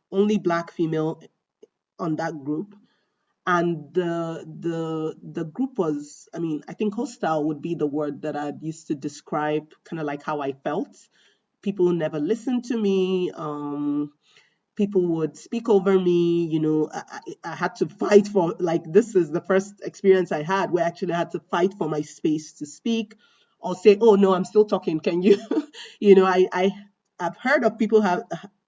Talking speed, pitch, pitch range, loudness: 185 wpm, 175 Hz, 155-200 Hz, -23 LUFS